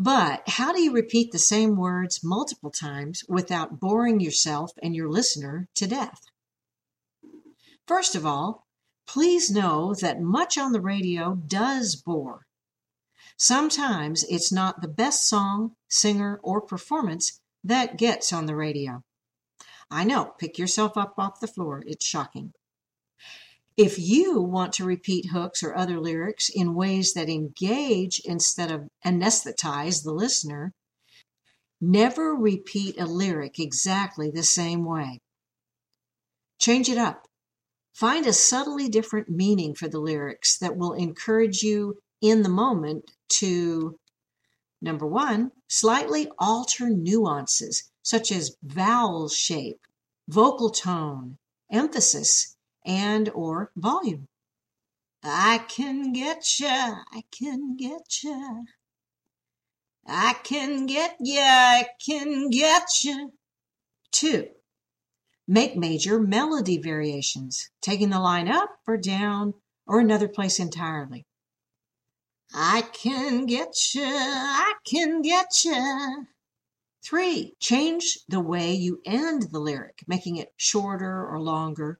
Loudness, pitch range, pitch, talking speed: -24 LUFS, 165-245 Hz, 200 Hz, 120 wpm